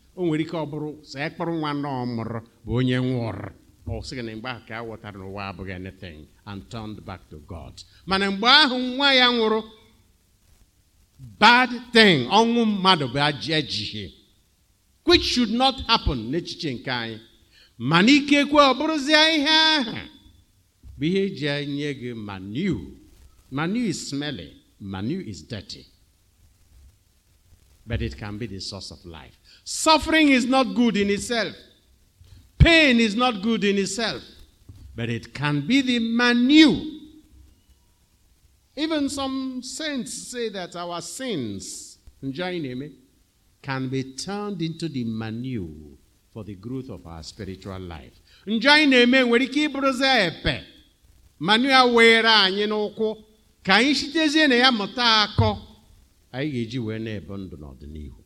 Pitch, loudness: 135 Hz, -21 LUFS